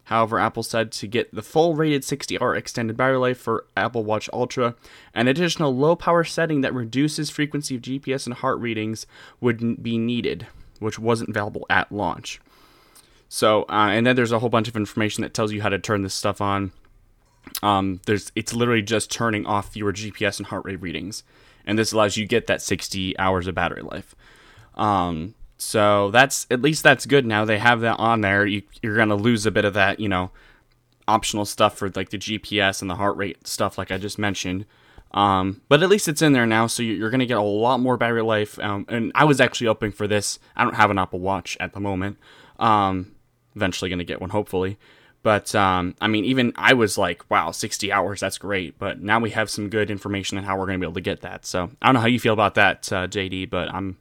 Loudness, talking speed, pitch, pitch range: -22 LUFS, 225 wpm, 105 Hz, 100-120 Hz